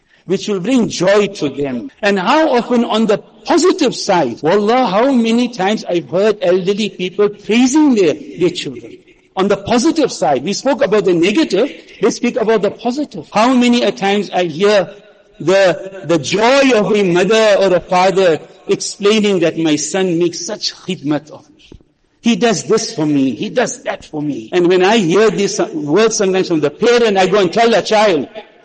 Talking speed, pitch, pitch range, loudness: 185 wpm, 205 Hz, 185-235 Hz, -14 LUFS